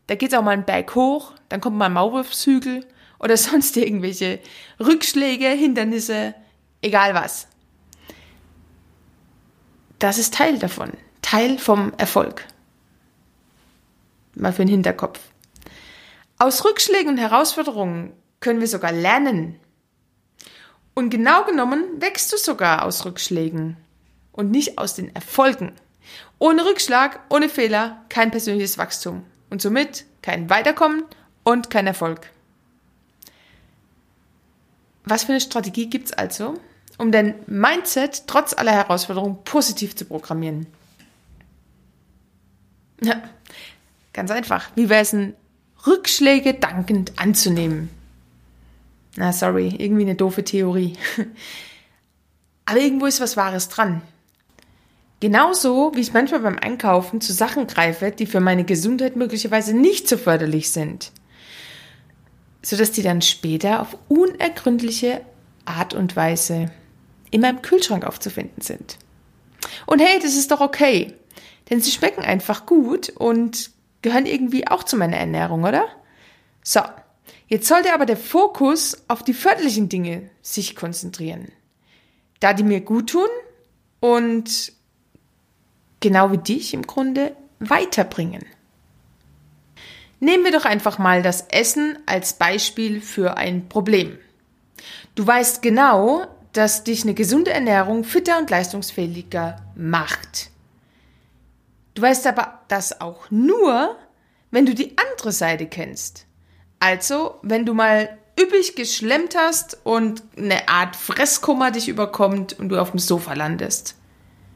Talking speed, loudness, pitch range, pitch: 120 wpm, -19 LUFS, 180-265 Hz, 220 Hz